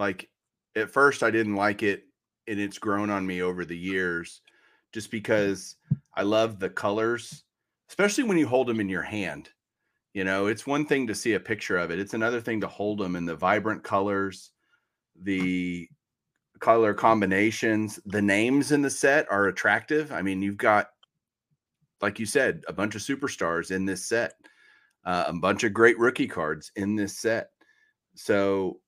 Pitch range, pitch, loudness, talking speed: 95-115 Hz, 105 Hz, -26 LUFS, 175 wpm